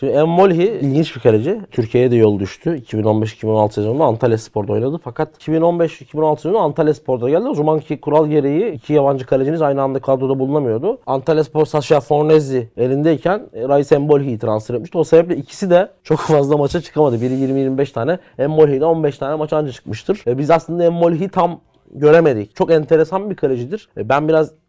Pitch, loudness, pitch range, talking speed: 150 Hz, -16 LUFS, 130-160 Hz, 175 wpm